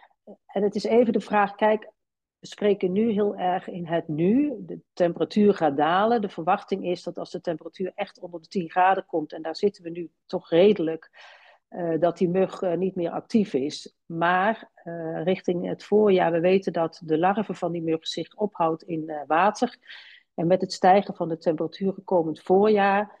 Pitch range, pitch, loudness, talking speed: 170-205 Hz, 185 Hz, -24 LUFS, 190 wpm